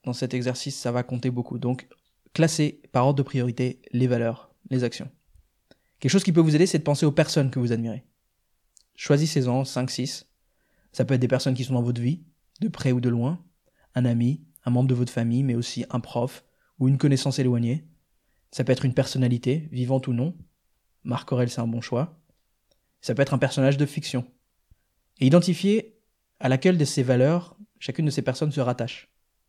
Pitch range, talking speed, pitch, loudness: 125-150 Hz, 195 wpm, 130 Hz, -25 LUFS